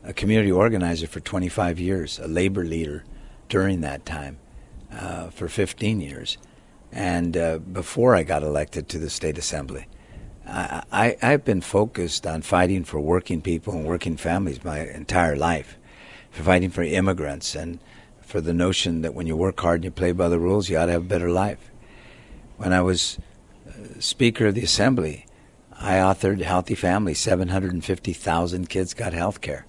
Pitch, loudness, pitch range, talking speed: 90 Hz, -23 LUFS, 80-95 Hz, 170 wpm